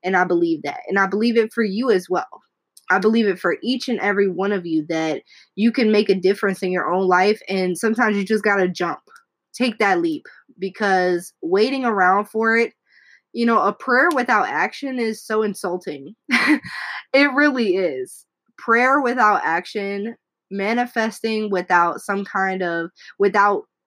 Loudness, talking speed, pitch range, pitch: -19 LUFS, 170 wpm, 185-230 Hz, 205 Hz